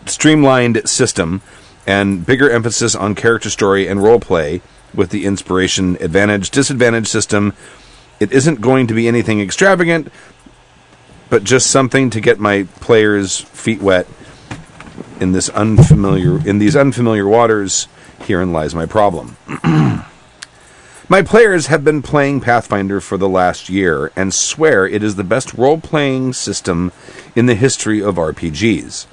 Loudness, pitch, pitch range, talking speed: -13 LUFS, 110 Hz, 100-130 Hz, 140 wpm